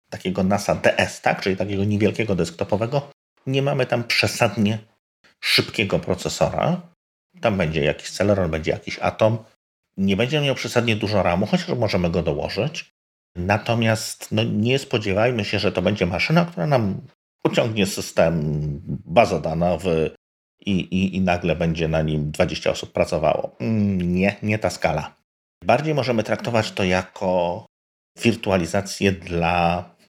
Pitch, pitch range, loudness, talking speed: 100 Hz, 90-115 Hz, -22 LUFS, 135 wpm